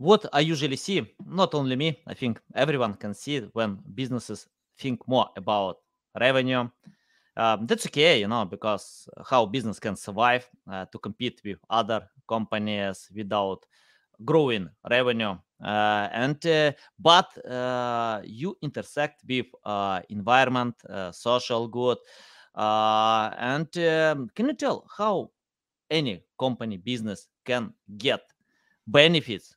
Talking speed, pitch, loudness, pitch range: 130 wpm, 125 Hz, -26 LUFS, 110-145 Hz